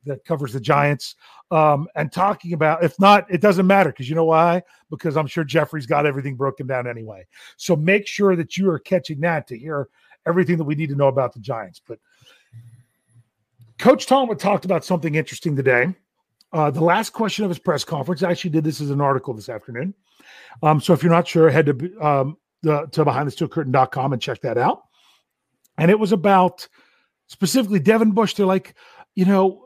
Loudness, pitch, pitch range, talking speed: -19 LUFS, 160 Hz, 140-185 Hz, 195 wpm